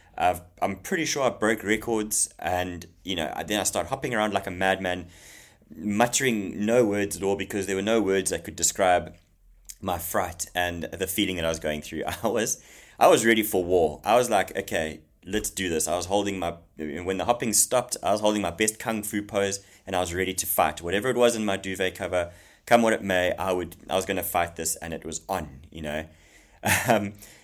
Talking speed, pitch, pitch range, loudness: 225 wpm, 95 Hz, 85-105 Hz, -26 LUFS